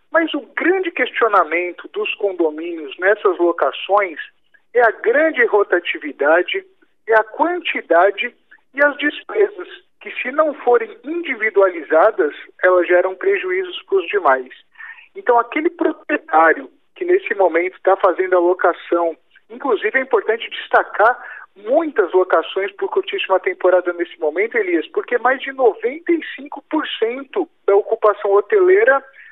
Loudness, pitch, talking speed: -17 LUFS, 300 Hz, 120 wpm